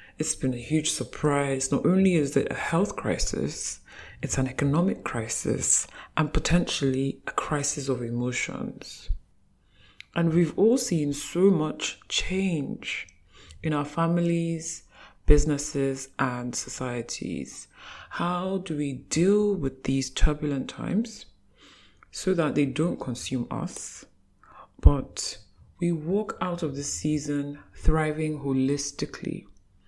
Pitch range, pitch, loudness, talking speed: 135-165 Hz, 145 Hz, -27 LUFS, 115 wpm